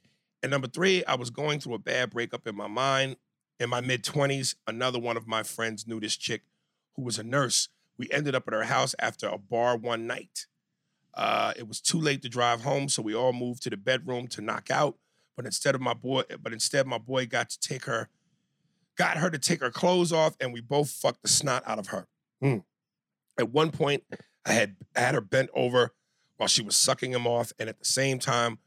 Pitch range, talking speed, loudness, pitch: 120-140 Hz, 230 wpm, -28 LUFS, 125 Hz